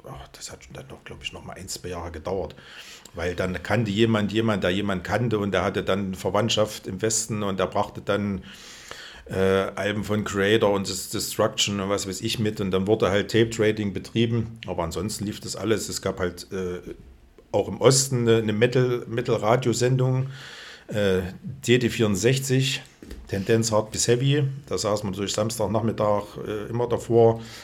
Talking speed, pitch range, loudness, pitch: 175 wpm, 95-115 Hz, -24 LUFS, 105 Hz